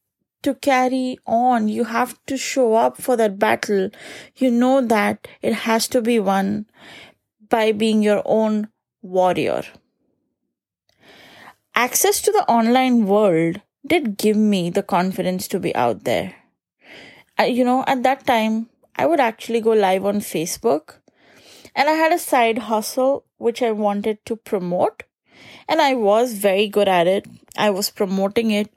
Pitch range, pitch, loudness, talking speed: 205-250 Hz, 225 Hz, -19 LUFS, 150 wpm